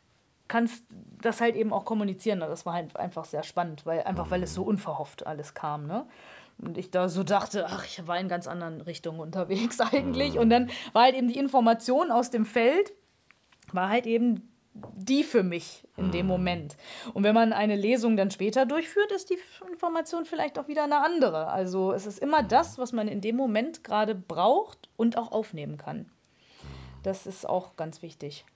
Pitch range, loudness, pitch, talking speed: 175-250 Hz, -28 LUFS, 210 Hz, 195 wpm